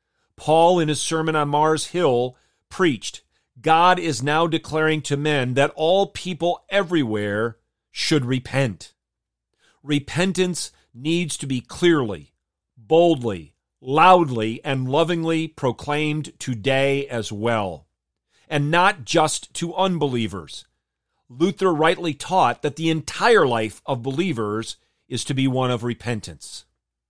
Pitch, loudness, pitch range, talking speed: 145 Hz, -21 LUFS, 115-165 Hz, 115 wpm